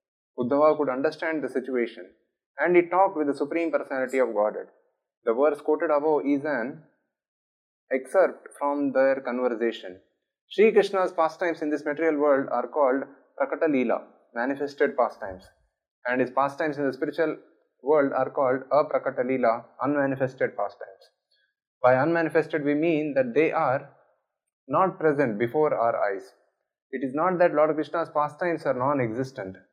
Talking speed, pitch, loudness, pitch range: 140 wpm, 145 Hz, -25 LUFS, 130-160 Hz